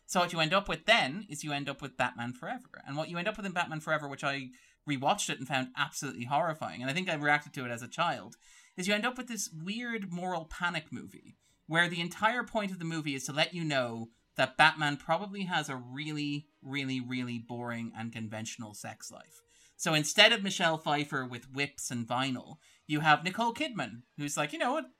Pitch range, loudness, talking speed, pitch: 130-180 Hz, -32 LUFS, 225 wpm, 150 Hz